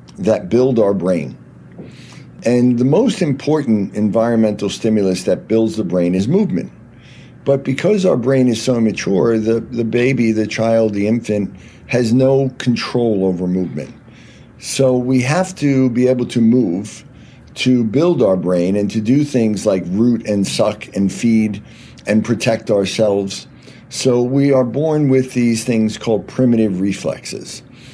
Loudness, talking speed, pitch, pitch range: -16 LUFS, 150 wpm, 115 Hz, 105-130 Hz